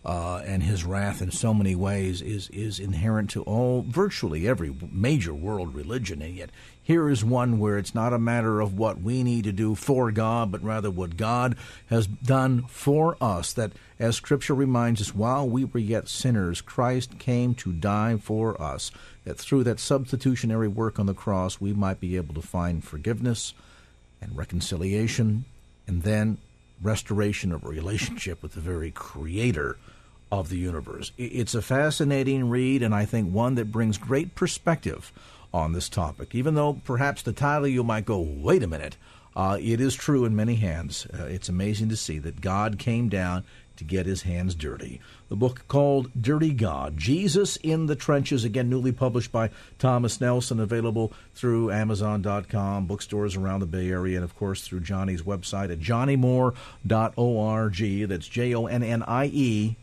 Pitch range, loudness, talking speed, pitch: 95-125 Hz, -26 LUFS, 175 wpm, 110 Hz